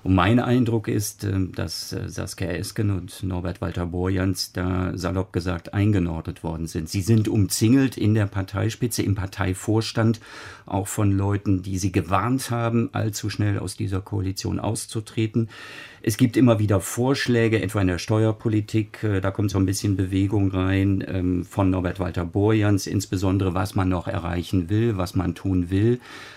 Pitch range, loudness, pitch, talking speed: 95-110 Hz, -23 LUFS, 100 Hz, 150 wpm